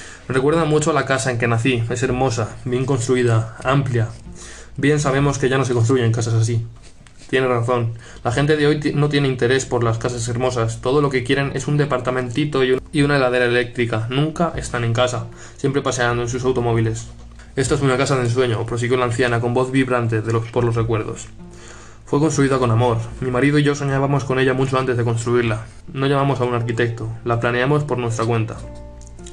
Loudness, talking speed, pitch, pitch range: -19 LUFS, 205 wpm, 125 Hz, 115-135 Hz